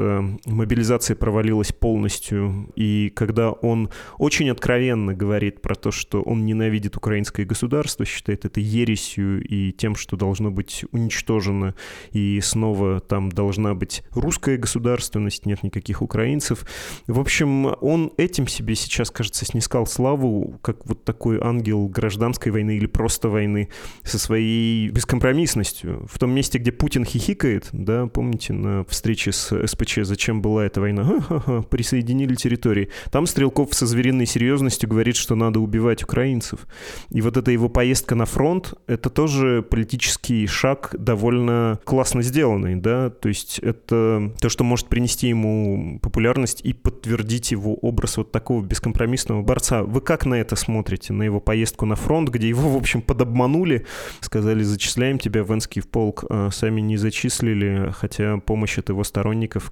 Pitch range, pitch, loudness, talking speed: 105-125 Hz, 115 Hz, -21 LUFS, 150 wpm